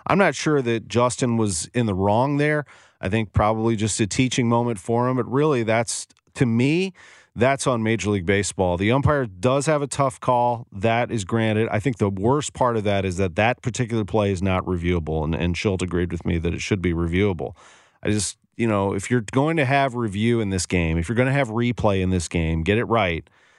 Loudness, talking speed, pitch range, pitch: -22 LUFS, 230 wpm, 100-125 Hz, 115 Hz